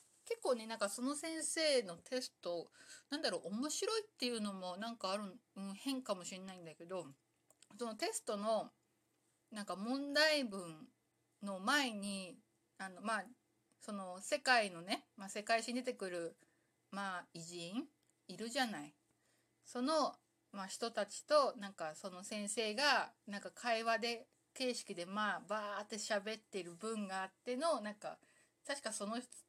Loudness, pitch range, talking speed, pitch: -40 LUFS, 190-255 Hz, 285 characters per minute, 220 Hz